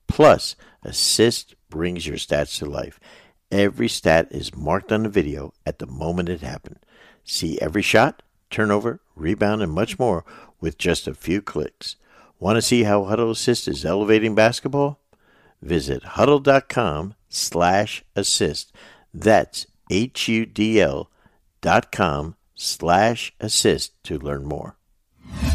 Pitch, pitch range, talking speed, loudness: 95 Hz, 80-110 Hz, 115 wpm, -21 LUFS